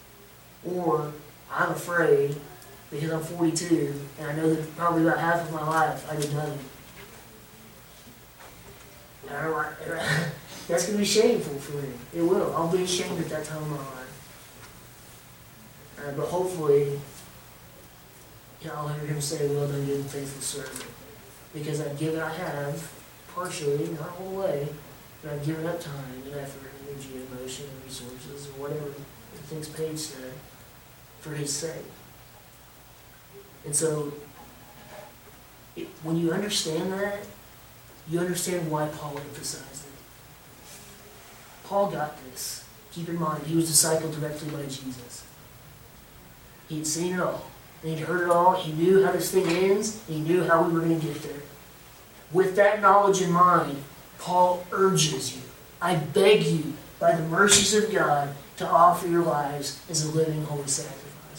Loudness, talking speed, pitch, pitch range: -26 LUFS, 155 wpm, 150 Hz, 140-170 Hz